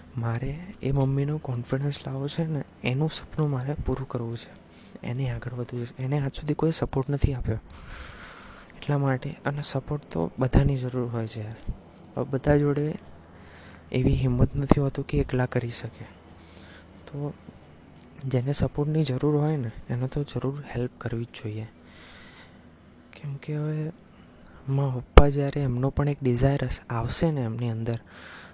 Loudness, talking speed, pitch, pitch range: -28 LUFS, 145 wpm, 130 Hz, 115-145 Hz